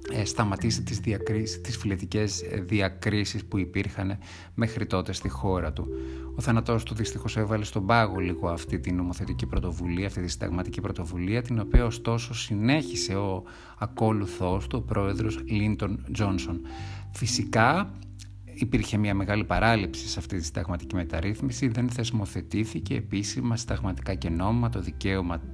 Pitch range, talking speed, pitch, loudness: 90-110 Hz, 135 wpm, 100 Hz, -28 LUFS